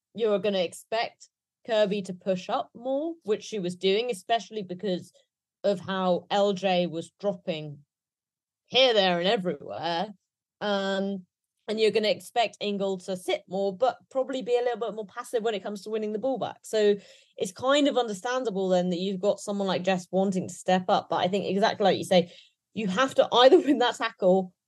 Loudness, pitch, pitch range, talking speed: -27 LUFS, 205 Hz, 185-230 Hz, 195 wpm